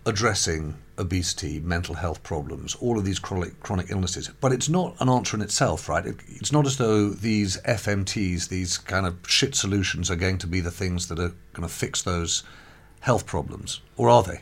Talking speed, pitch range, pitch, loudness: 200 wpm, 85-110 Hz, 95 Hz, -25 LUFS